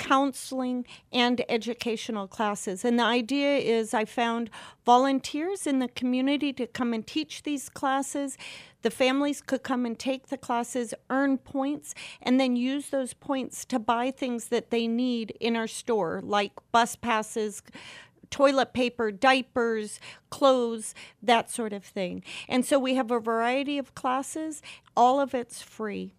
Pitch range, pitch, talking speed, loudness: 230-270 Hz, 245 Hz, 155 wpm, -27 LUFS